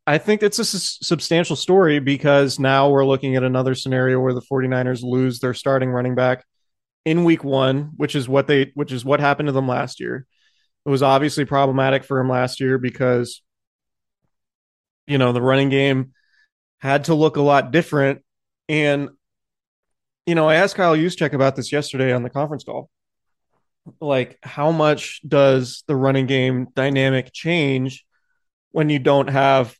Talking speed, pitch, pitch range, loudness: 170 wpm, 135 Hz, 130-150 Hz, -19 LUFS